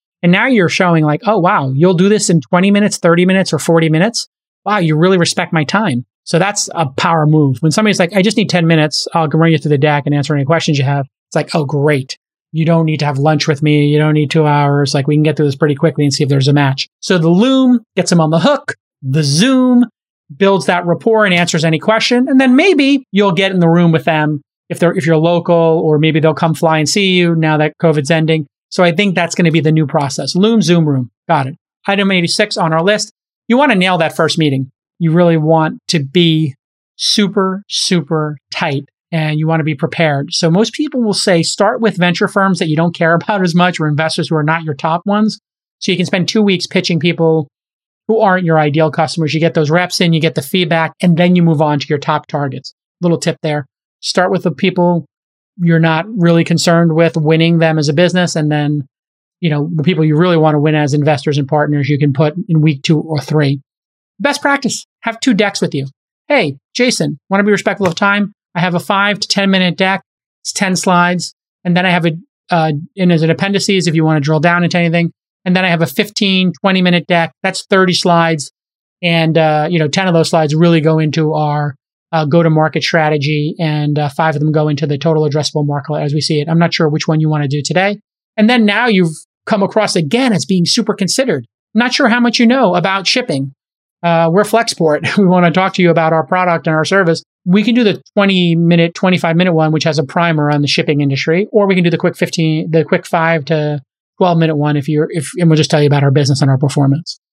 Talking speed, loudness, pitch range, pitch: 245 wpm, -13 LUFS, 155-190 Hz, 165 Hz